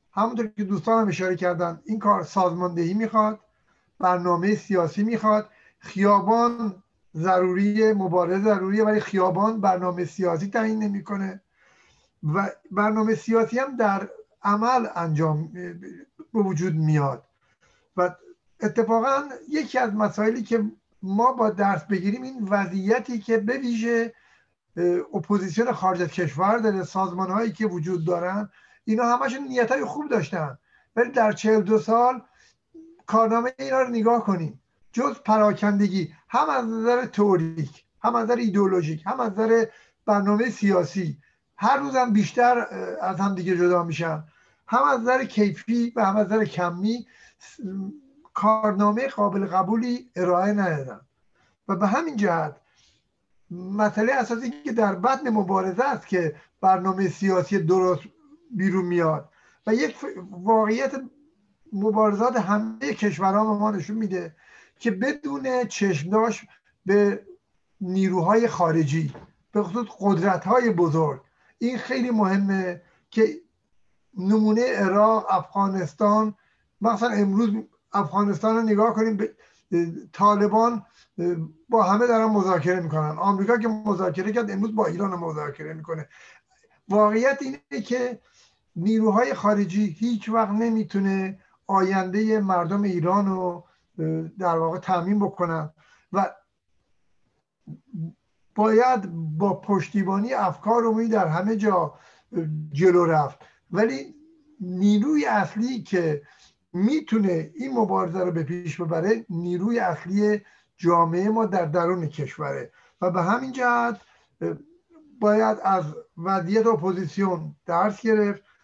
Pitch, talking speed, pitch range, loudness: 205 Hz, 120 wpm, 180-225 Hz, -23 LUFS